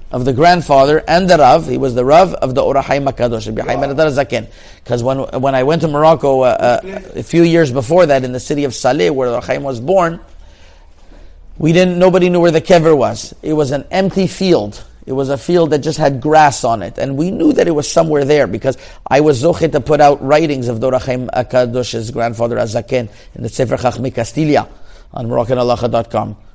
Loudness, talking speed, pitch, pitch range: -13 LUFS, 200 wpm, 135 Hz, 120-155 Hz